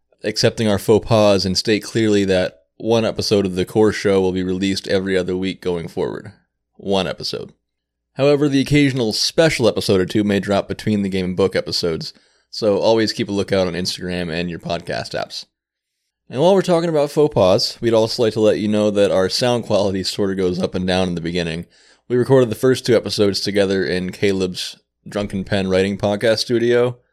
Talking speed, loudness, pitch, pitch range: 200 wpm, -18 LUFS, 100 Hz, 95-115 Hz